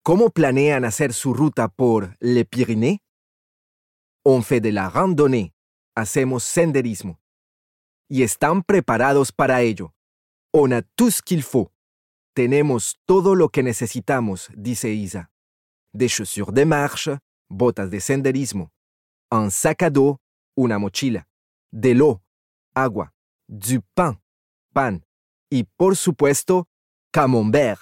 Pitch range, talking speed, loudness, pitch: 95-140 Hz, 115 wpm, -20 LUFS, 120 Hz